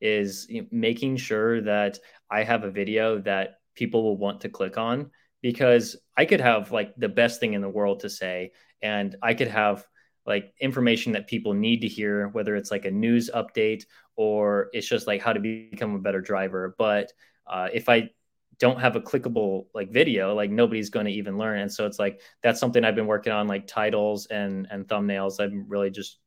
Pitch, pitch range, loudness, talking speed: 105 Hz, 100-115 Hz, -25 LUFS, 205 wpm